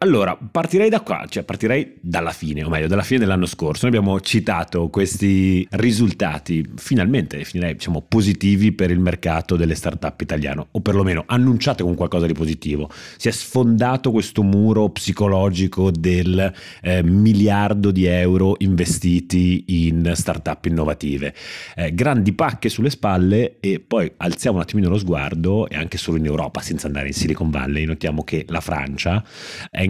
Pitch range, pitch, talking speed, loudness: 80-105 Hz, 90 Hz, 160 wpm, -19 LUFS